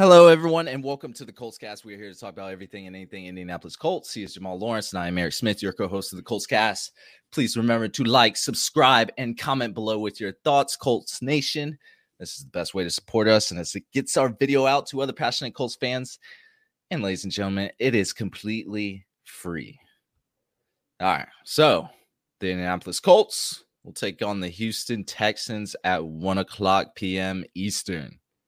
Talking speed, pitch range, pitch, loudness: 195 wpm, 95-125 Hz, 105 Hz, -24 LUFS